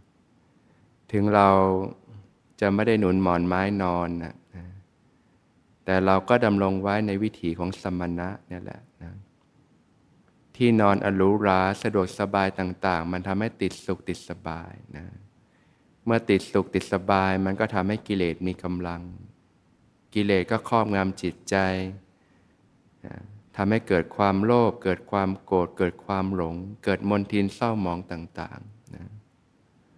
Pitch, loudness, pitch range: 95 Hz, -25 LUFS, 90-105 Hz